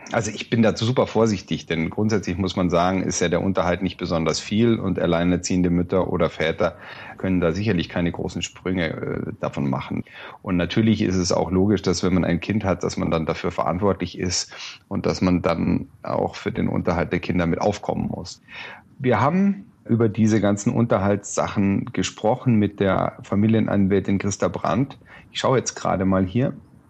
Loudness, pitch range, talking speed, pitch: -22 LUFS, 90-105 Hz, 180 wpm, 95 Hz